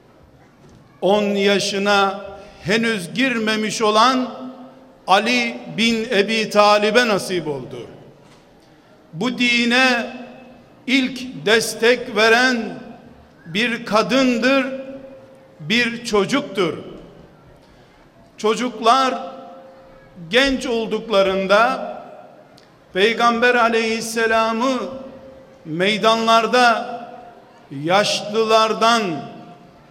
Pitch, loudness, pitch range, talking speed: 225 Hz, -17 LUFS, 200-245 Hz, 55 wpm